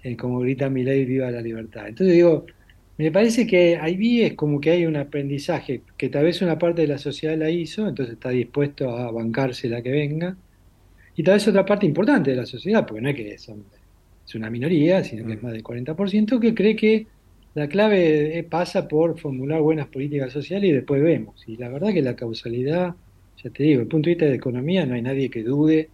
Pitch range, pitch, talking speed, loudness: 125-170 Hz, 145 Hz, 225 wpm, -22 LUFS